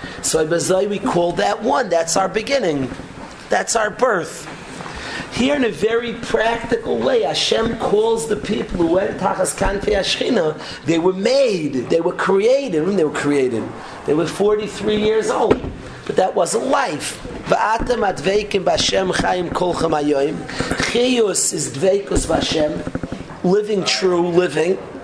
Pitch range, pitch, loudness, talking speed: 180-225 Hz, 200 Hz, -18 LUFS, 150 wpm